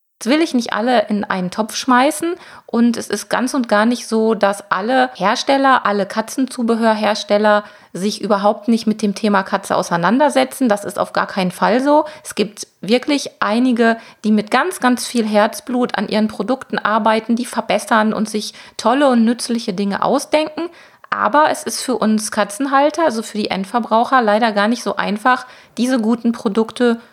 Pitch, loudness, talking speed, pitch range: 225 Hz, -17 LUFS, 175 wpm, 210-255 Hz